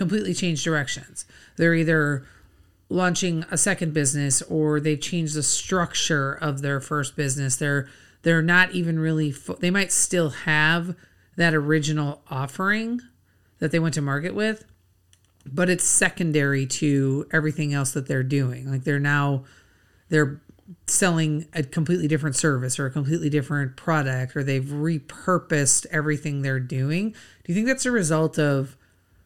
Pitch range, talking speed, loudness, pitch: 140-165 Hz, 150 wpm, -23 LUFS, 150 Hz